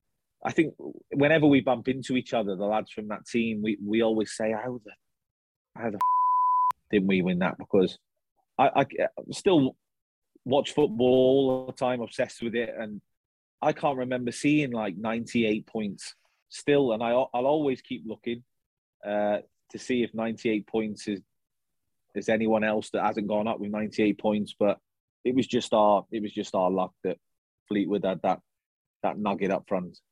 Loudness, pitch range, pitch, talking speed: -27 LUFS, 105-125 Hz, 110 Hz, 185 wpm